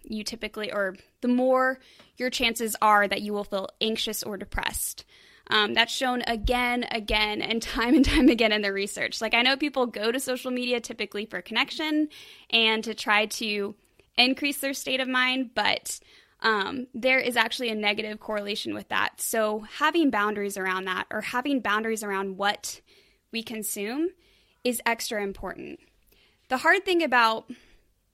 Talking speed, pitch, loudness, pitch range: 165 wpm, 230 Hz, -25 LUFS, 210-255 Hz